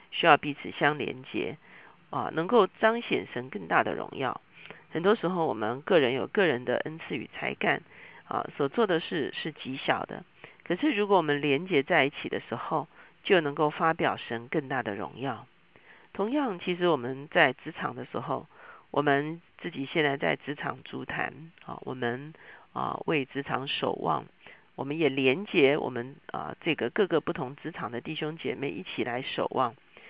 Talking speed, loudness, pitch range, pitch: 255 characters per minute, -29 LUFS, 140-175 Hz, 155 Hz